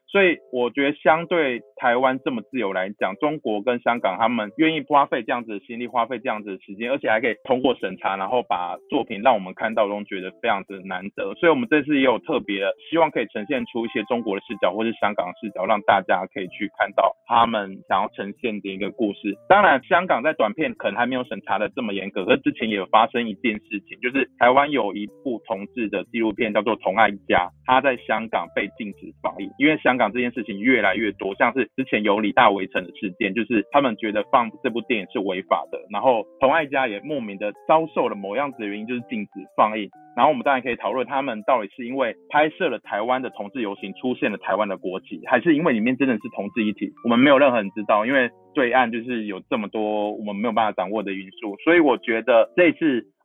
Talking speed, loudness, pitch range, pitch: 365 characters per minute, -22 LUFS, 105-135 Hz, 115 Hz